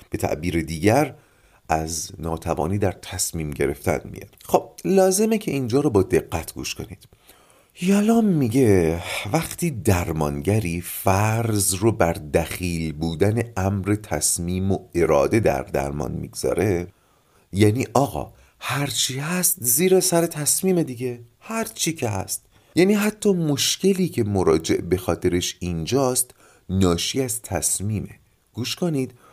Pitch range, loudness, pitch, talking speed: 90-140 Hz, -22 LUFS, 105 Hz, 120 wpm